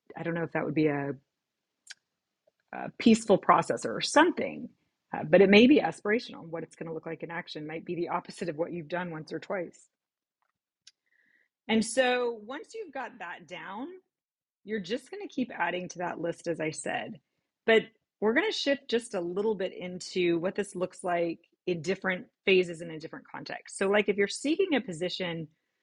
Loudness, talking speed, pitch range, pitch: -29 LUFS, 195 wpm, 170-230 Hz, 185 Hz